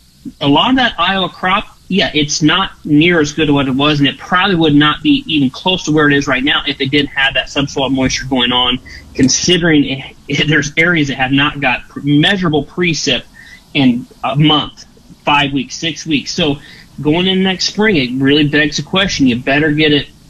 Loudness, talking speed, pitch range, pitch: -13 LUFS, 205 wpm, 140-175 Hz, 150 Hz